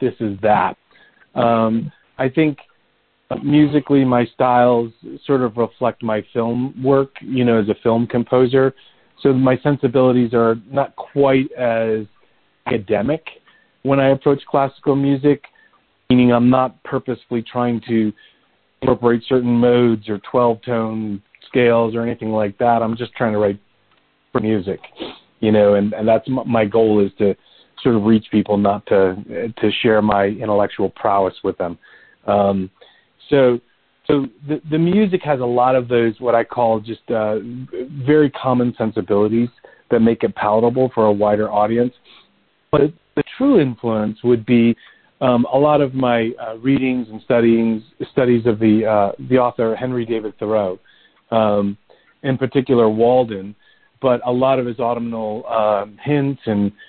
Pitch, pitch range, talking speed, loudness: 120 Hz, 110-130 Hz, 150 wpm, -17 LUFS